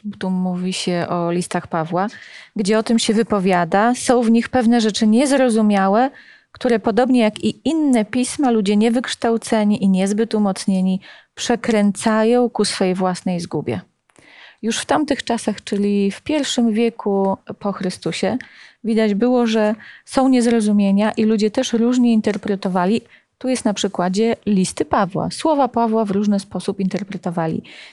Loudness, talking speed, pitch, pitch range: -18 LUFS, 140 wpm, 215 Hz, 195-235 Hz